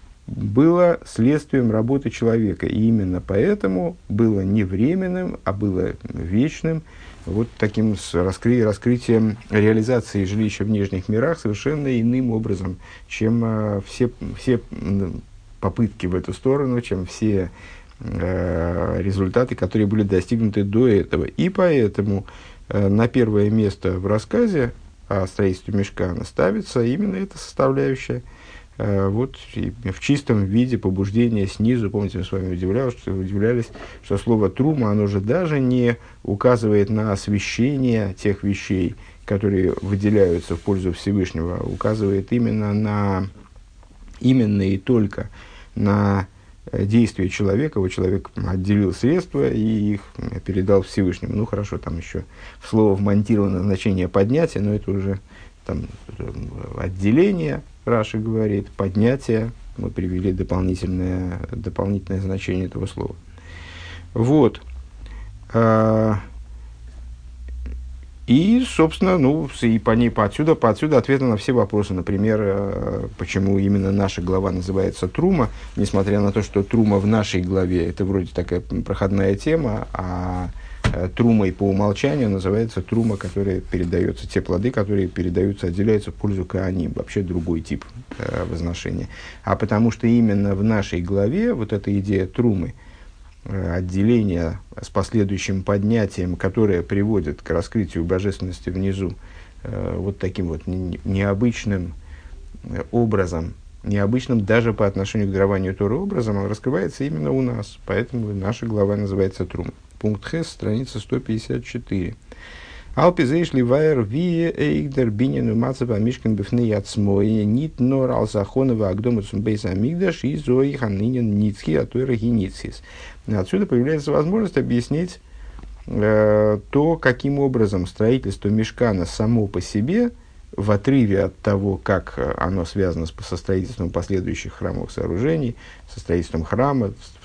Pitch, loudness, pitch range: 100 Hz, -21 LUFS, 95-115 Hz